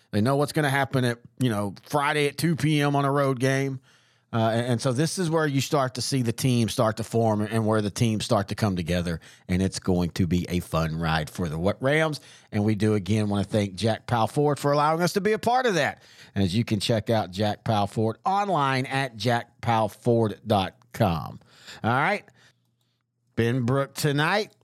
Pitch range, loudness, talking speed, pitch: 105-140 Hz, -25 LUFS, 210 wpm, 120 Hz